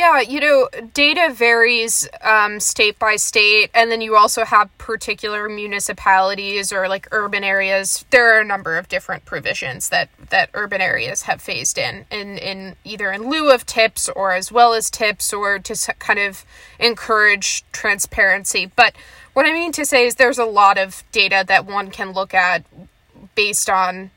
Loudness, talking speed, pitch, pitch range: -16 LUFS, 175 wpm, 210 Hz, 195-235 Hz